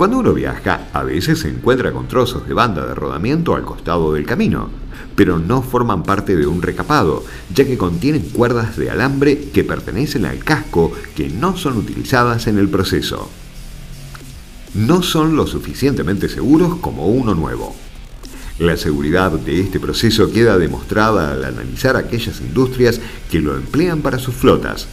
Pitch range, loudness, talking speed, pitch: 80-130 Hz, -16 LUFS, 160 wpm, 105 Hz